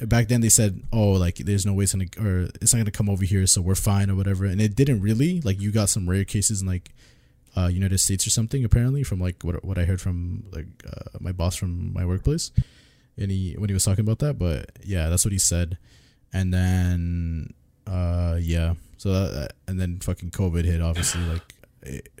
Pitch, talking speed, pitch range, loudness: 95 Hz, 225 wpm, 90-105 Hz, -23 LUFS